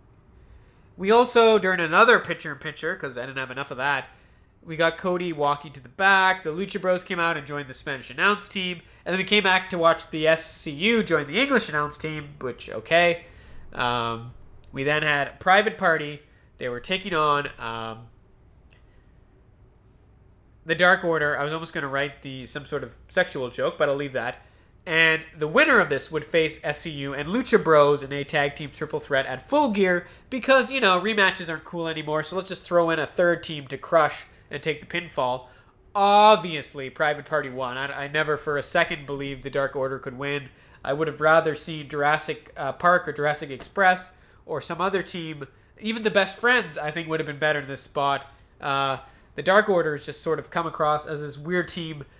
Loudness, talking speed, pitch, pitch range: -23 LUFS, 205 wpm, 155 Hz, 140-180 Hz